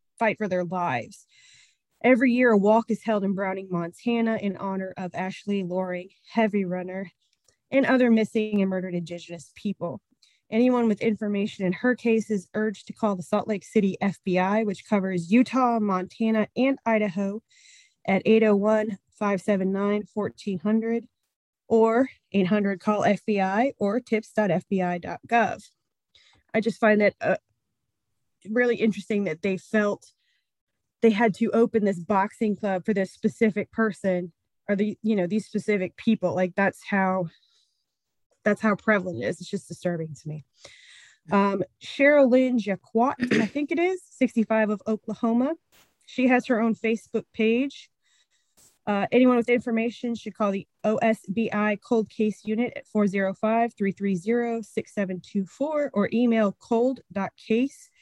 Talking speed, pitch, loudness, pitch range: 140 wpm, 215 Hz, -25 LUFS, 195-230 Hz